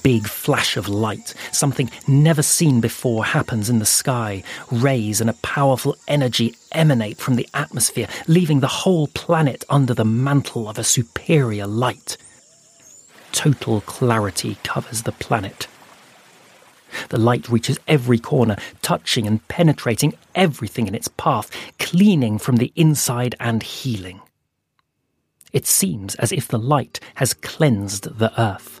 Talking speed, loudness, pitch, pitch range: 135 wpm, -19 LUFS, 120 Hz, 115-140 Hz